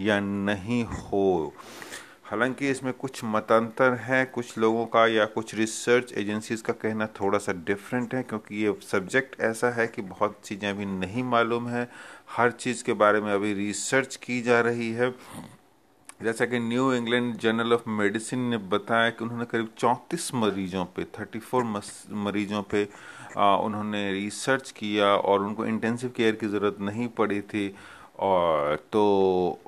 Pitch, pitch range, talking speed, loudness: 110 Hz, 105-120 Hz, 155 wpm, -26 LUFS